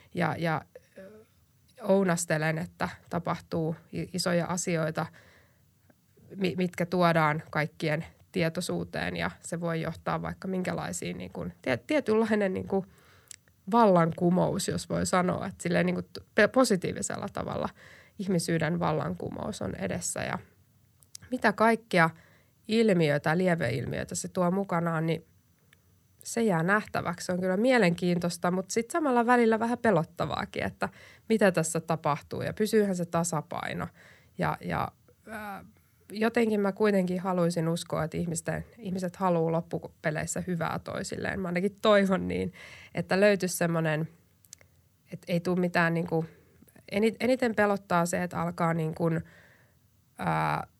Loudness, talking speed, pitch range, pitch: -29 LUFS, 120 wpm, 160-200 Hz, 175 Hz